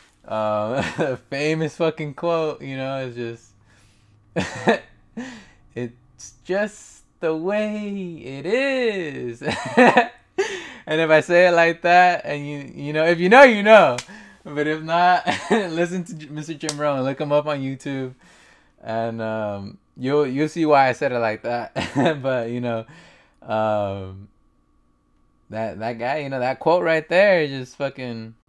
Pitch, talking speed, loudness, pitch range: 145 Hz, 150 wpm, -20 LUFS, 115-170 Hz